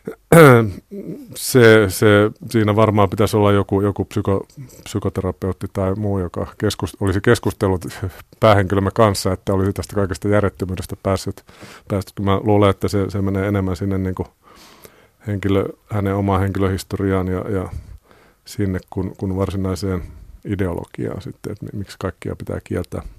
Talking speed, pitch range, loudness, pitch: 130 wpm, 95-105 Hz, -18 LUFS, 100 Hz